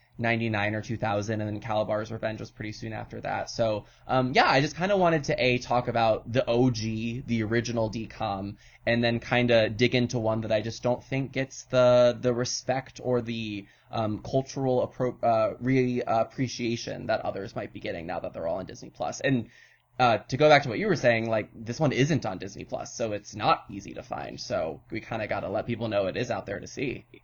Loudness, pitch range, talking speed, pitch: -27 LUFS, 110-125 Hz, 225 wpm, 120 Hz